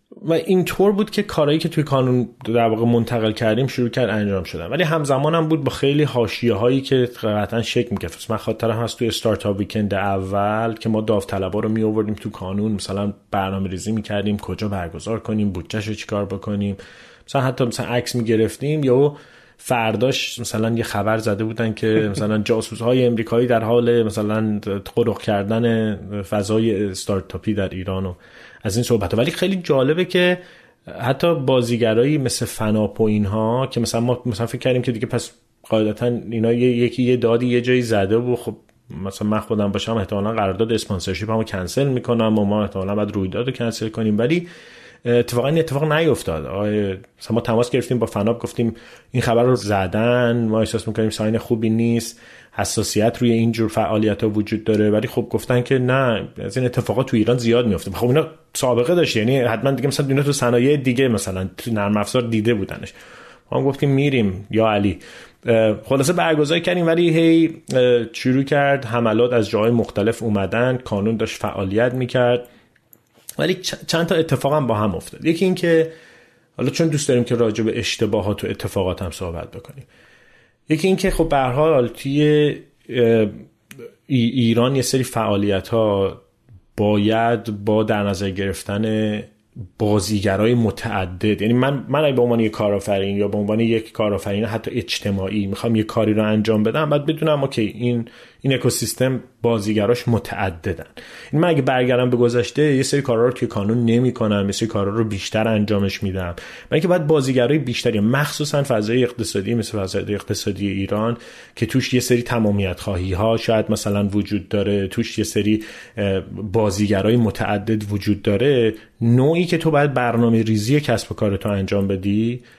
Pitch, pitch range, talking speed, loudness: 115 Hz, 105-125 Hz, 170 wpm, -20 LUFS